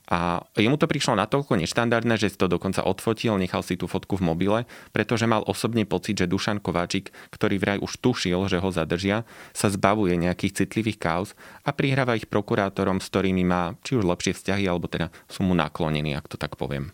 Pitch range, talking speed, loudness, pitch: 90-110 Hz, 200 wpm, -25 LUFS, 95 Hz